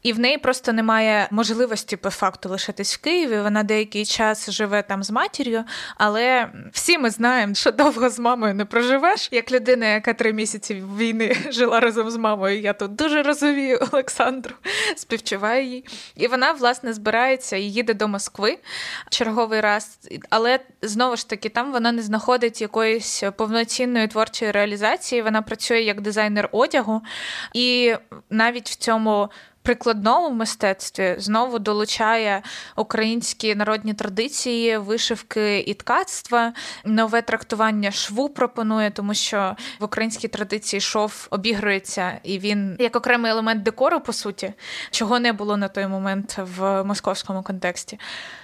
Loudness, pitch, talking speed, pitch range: -21 LUFS, 225 Hz, 140 wpm, 210-240 Hz